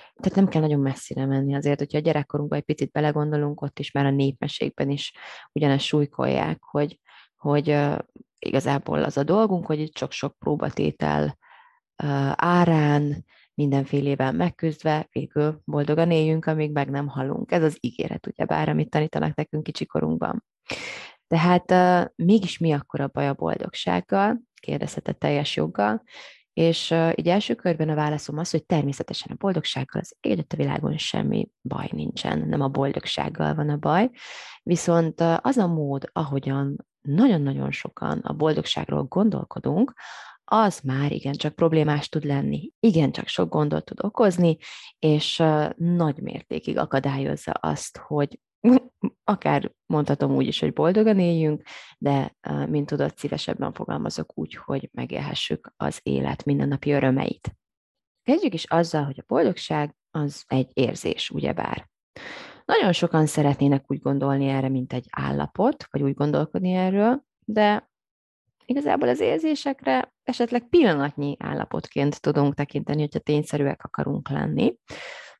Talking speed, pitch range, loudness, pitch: 135 wpm, 140-170 Hz, -24 LUFS, 150 Hz